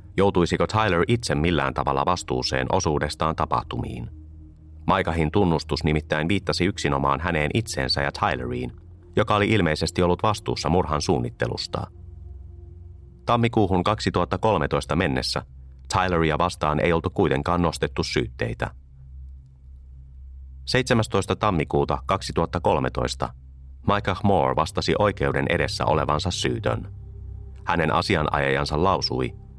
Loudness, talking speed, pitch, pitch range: -23 LUFS, 95 wpm, 85 Hz, 70-95 Hz